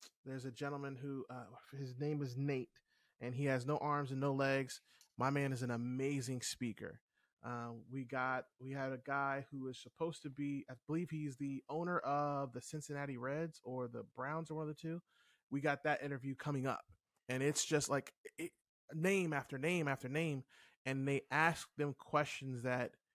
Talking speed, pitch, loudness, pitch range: 190 wpm, 140 Hz, -41 LUFS, 130-150 Hz